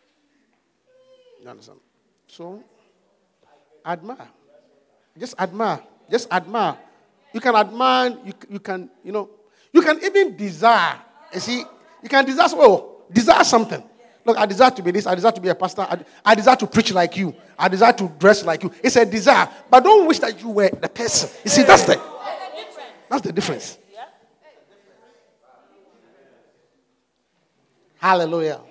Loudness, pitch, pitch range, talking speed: -17 LUFS, 230 Hz, 190-260 Hz, 150 wpm